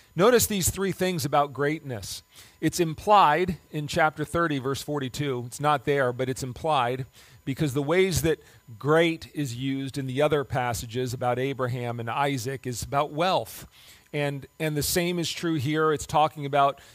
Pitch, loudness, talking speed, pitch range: 145 Hz, -26 LUFS, 165 wpm, 130-155 Hz